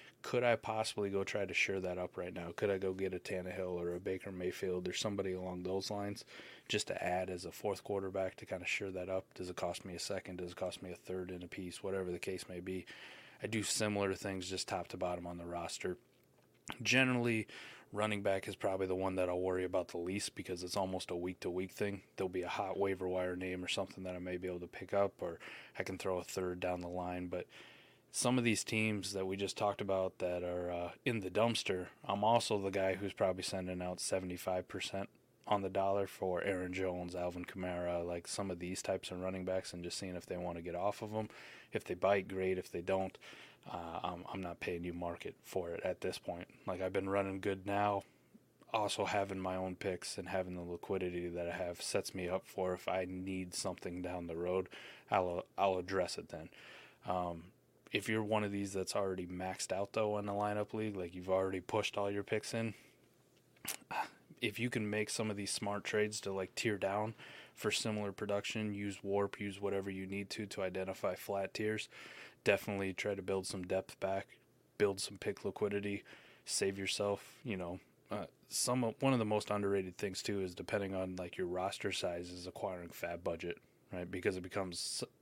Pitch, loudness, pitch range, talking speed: 95 Hz, -39 LUFS, 90-100 Hz, 220 wpm